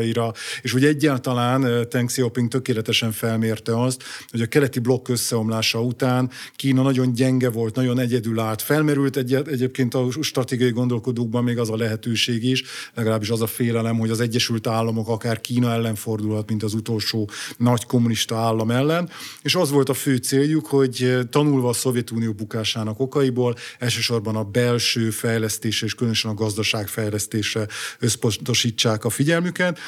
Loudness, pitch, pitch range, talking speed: -21 LUFS, 120 Hz, 115-130 Hz, 150 wpm